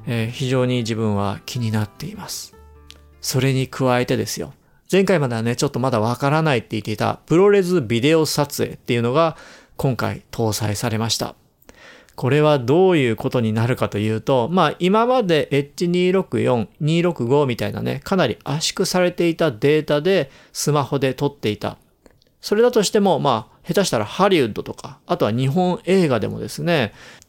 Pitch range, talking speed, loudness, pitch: 115-165 Hz, 345 characters per minute, -19 LUFS, 135 Hz